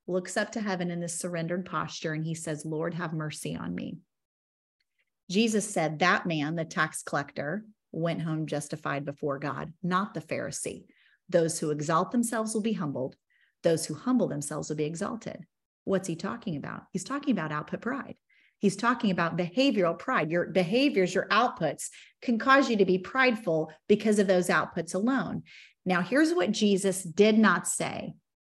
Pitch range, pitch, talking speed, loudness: 160-215 Hz, 180 Hz, 170 wpm, -28 LUFS